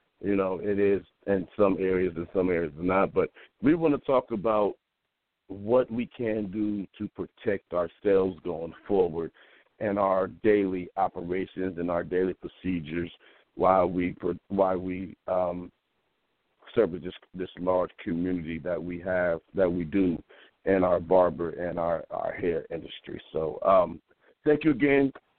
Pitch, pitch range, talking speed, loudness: 95 Hz, 90-100 Hz, 150 wpm, -28 LUFS